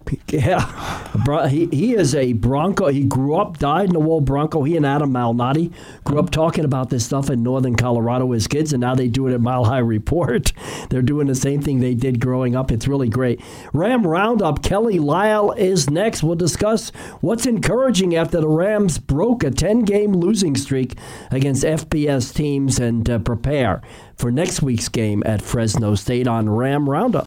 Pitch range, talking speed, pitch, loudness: 125-160 Hz, 185 wpm, 140 Hz, -19 LUFS